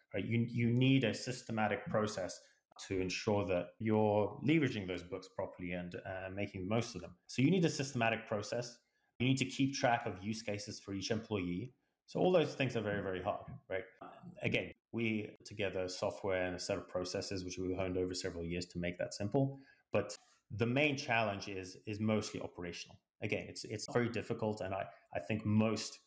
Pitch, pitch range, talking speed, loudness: 105 Hz, 95-120 Hz, 195 wpm, -37 LUFS